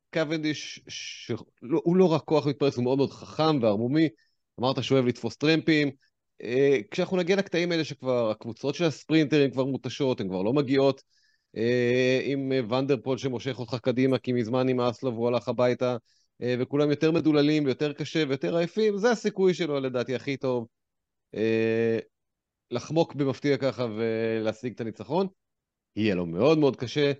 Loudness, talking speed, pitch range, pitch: -26 LUFS, 160 wpm, 120-155 Hz, 135 Hz